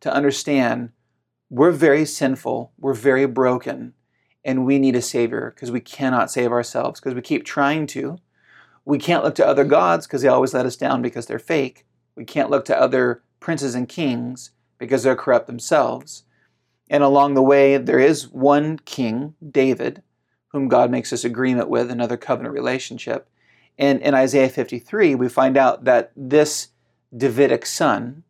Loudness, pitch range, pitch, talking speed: -19 LUFS, 125-140 Hz, 130 Hz, 170 wpm